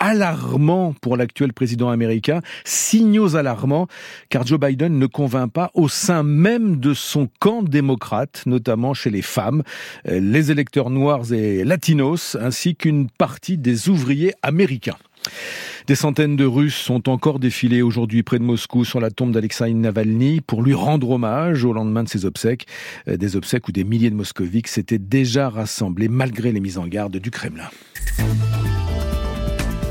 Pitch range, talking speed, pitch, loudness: 115-150 Hz, 155 wpm, 130 Hz, -19 LUFS